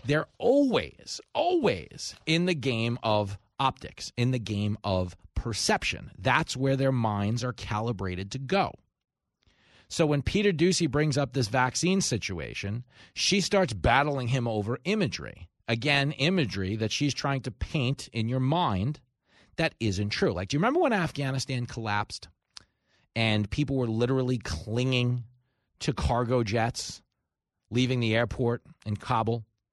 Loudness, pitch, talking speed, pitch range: -28 LUFS, 125 Hz, 140 wpm, 110-140 Hz